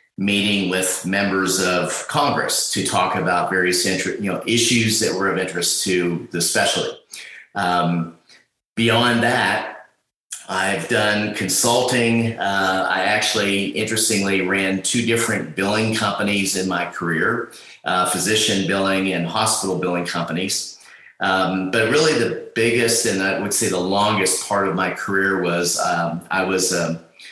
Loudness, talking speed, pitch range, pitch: -19 LUFS, 145 wpm, 90-105 Hz, 95 Hz